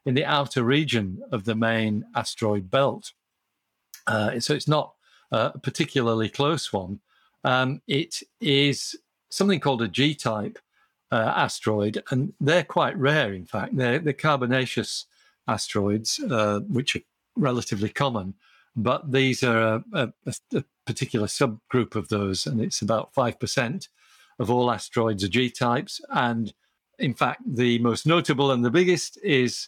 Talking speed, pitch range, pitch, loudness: 150 wpm, 110-140 Hz, 125 Hz, -25 LUFS